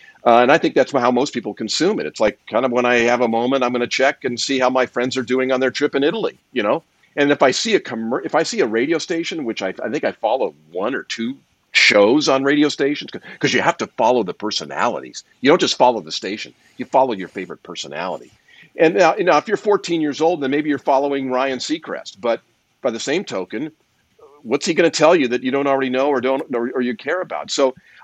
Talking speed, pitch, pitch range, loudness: 255 wpm, 135 Hz, 125-145 Hz, -18 LUFS